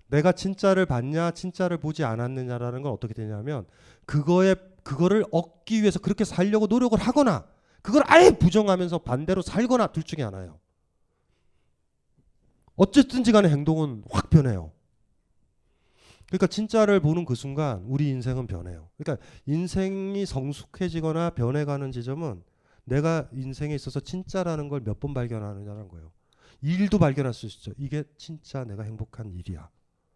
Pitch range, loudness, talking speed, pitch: 120-185 Hz, -24 LUFS, 330 characters per minute, 150 Hz